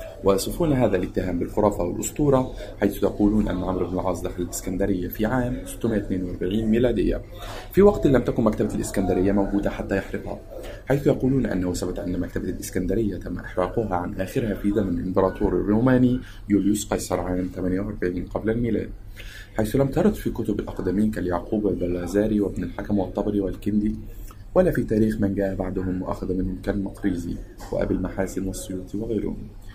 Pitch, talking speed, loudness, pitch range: 100 Hz, 145 wpm, -24 LUFS, 95-110 Hz